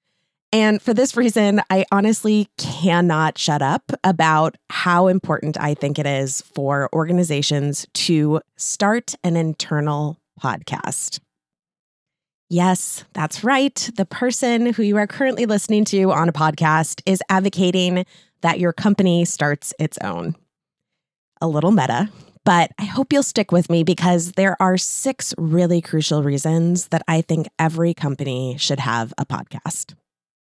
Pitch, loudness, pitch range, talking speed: 175 Hz, -19 LUFS, 155-200 Hz, 140 wpm